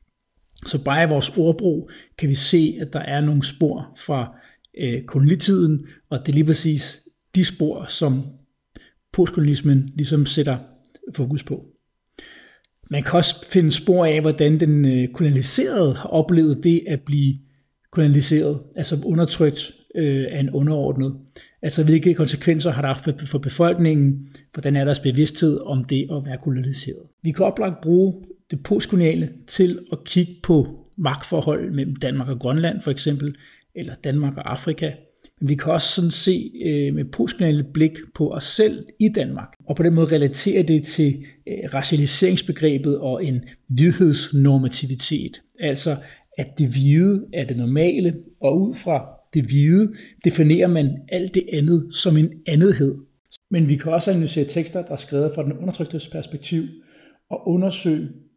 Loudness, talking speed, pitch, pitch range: -20 LUFS, 155 wpm, 155 Hz, 140-170 Hz